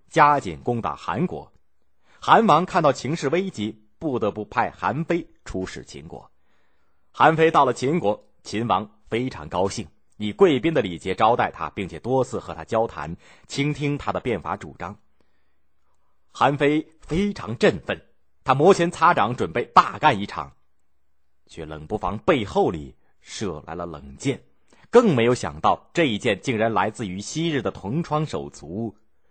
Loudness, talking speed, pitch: -22 LUFS, 225 characters per minute, 105 Hz